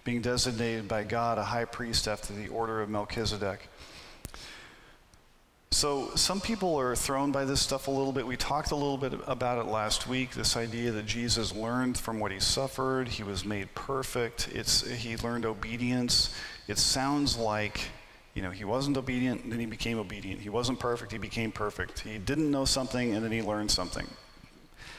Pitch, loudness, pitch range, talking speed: 115 Hz, -30 LUFS, 105-130 Hz, 185 wpm